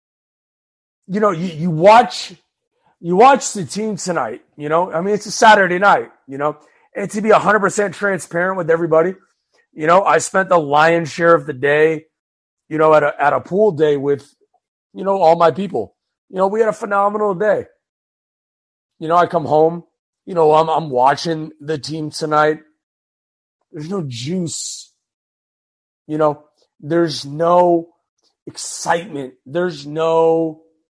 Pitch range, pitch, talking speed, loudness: 155-195 Hz, 165 Hz, 160 wpm, -16 LUFS